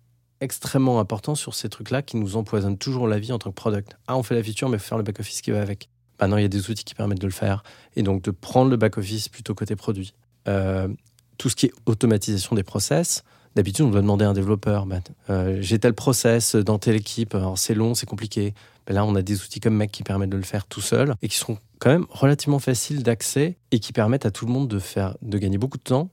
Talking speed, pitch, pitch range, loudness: 260 wpm, 110 Hz, 105-125 Hz, -23 LUFS